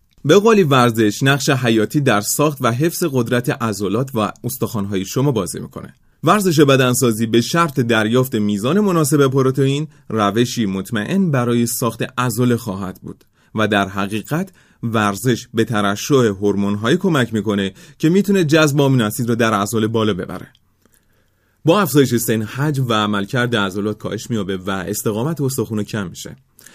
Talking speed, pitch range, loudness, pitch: 140 wpm, 105-140 Hz, -17 LUFS, 120 Hz